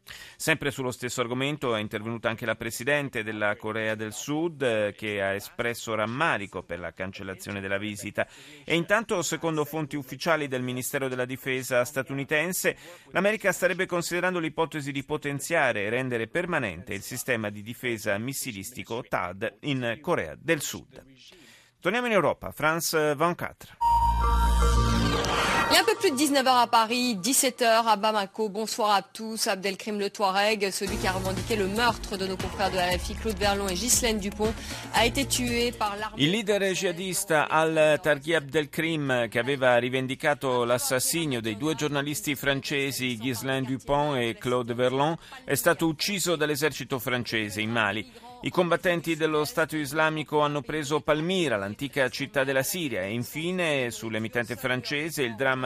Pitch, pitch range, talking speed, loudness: 150 Hz, 125-180 Hz, 150 wpm, -27 LUFS